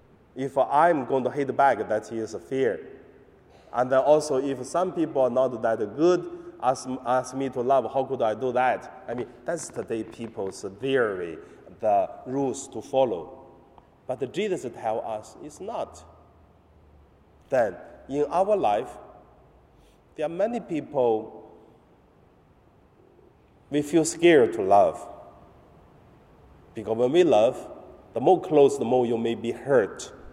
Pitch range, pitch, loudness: 110-140 Hz, 130 Hz, -25 LUFS